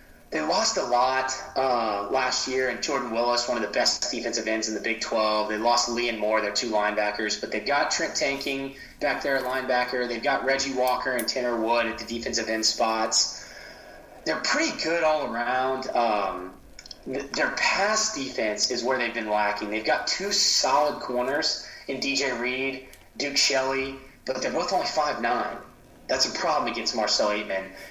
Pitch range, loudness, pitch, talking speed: 110-130 Hz, -25 LUFS, 120 Hz, 180 wpm